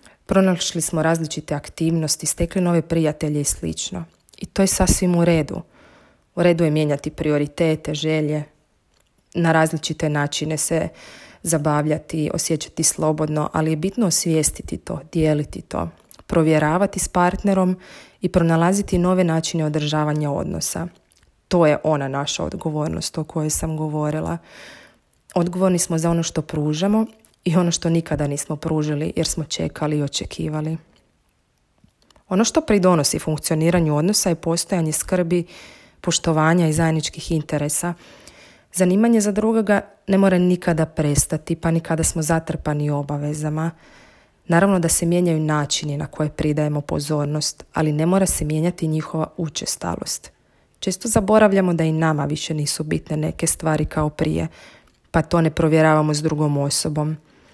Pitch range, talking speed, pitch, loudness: 150-175 Hz, 135 wpm, 160 Hz, -20 LUFS